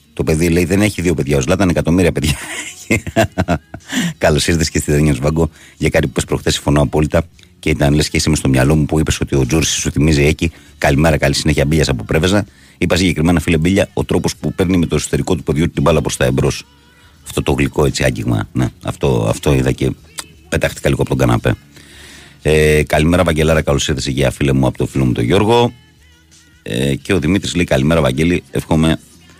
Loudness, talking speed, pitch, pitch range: -15 LUFS, 205 wpm, 80 Hz, 70-85 Hz